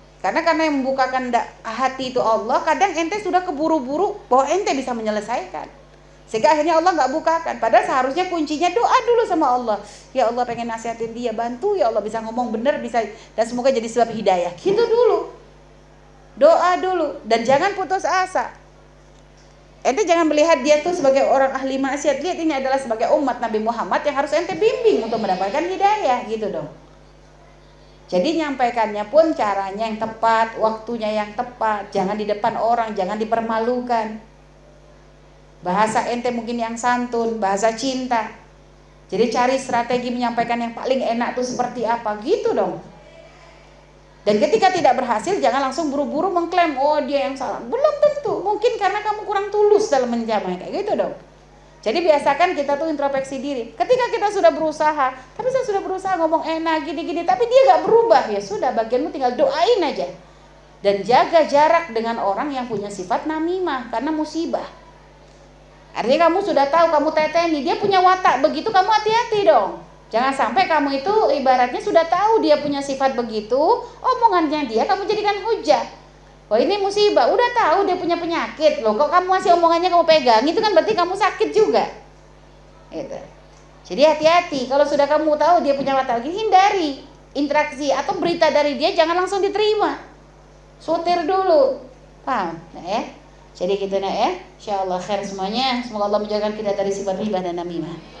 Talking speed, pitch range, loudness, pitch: 165 wpm, 230-350 Hz, -19 LUFS, 285 Hz